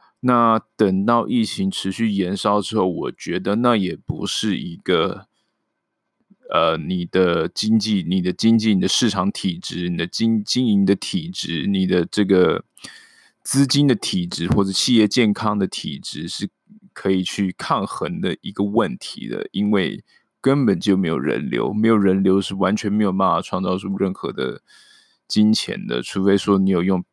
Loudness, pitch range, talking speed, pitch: -20 LUFS, 95-120 Hz, 240 characters per minute, 105 Hz